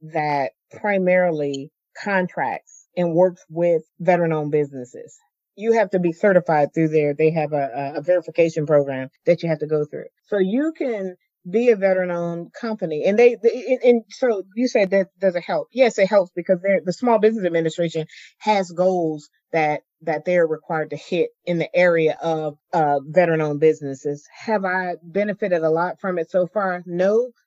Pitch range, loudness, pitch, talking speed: 155-200 Hz, -21 LUFS, 175 Hz, 175 wpm